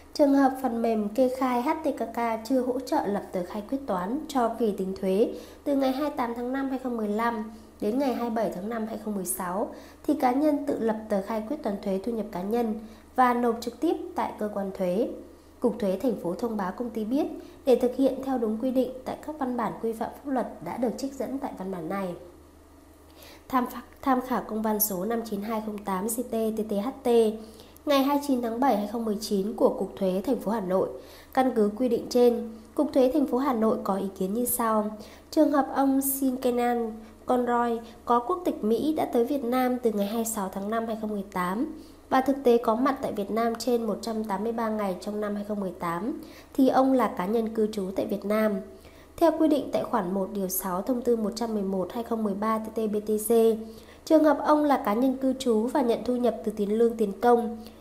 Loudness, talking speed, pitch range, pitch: -27 LUFS, 205 wpm, 210-260 Hz, 230 Hz